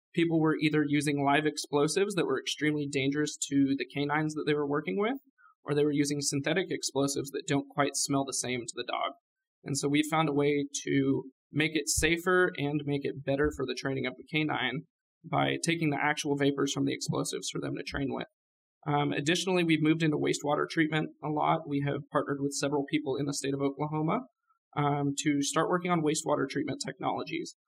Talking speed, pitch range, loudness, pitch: 205 wpm, 140-155 Hz, -30 LUFS, 145 Hz